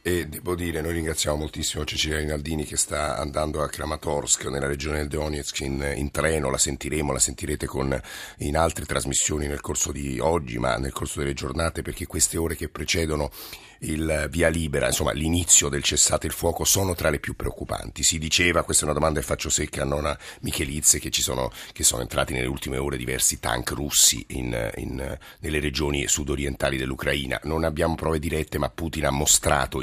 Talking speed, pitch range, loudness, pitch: 185 wpm, 70-80 Hz, -24 LUFS, 75 Hz